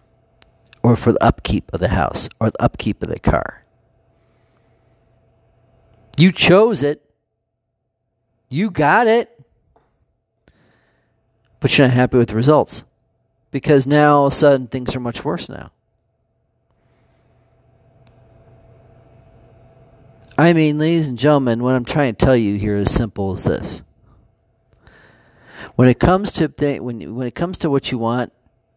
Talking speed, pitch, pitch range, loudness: 140 wpm, 115 Hz, 110-135 Hz, -17 LUFS